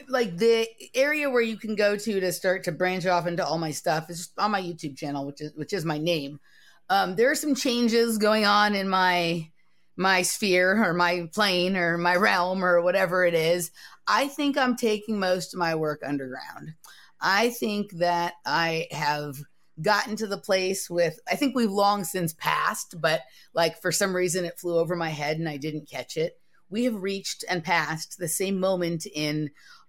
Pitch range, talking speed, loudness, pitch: 165-210 Hz, 200 wpm, -25 LUFS, 180 Hz